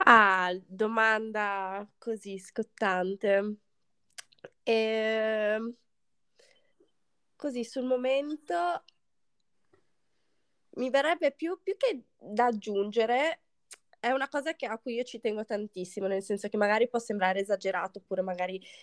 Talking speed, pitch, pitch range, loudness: 110 wpm, 220 Hz, 200-260 Hz, -30 LUFS